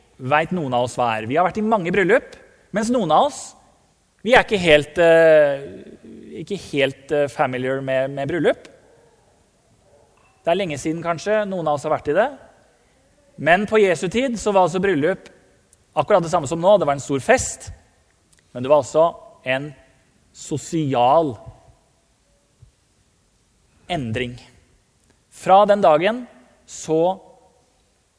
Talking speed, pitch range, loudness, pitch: 145 wpm, 130-185 Hz, -19 LUFS, 150 Hz